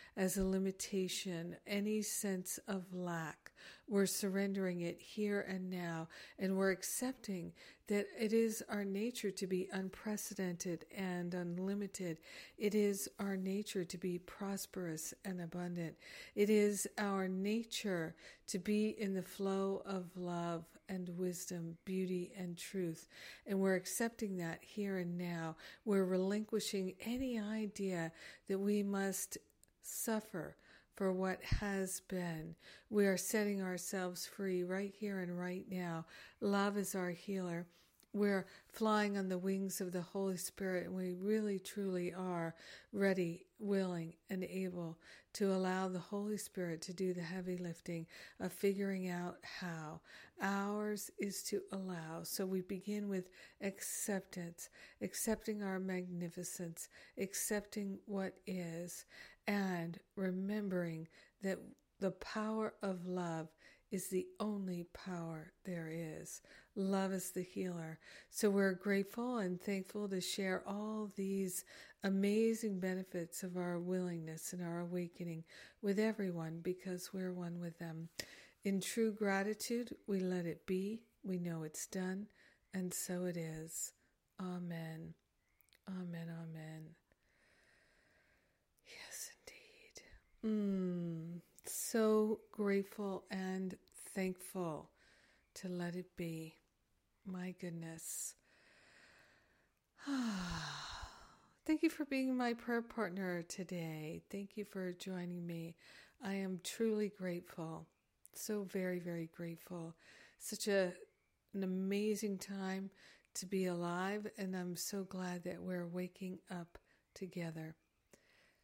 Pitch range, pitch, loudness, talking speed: 175-200 Hz, 190 Hz, -41 LUFS, 120 wpm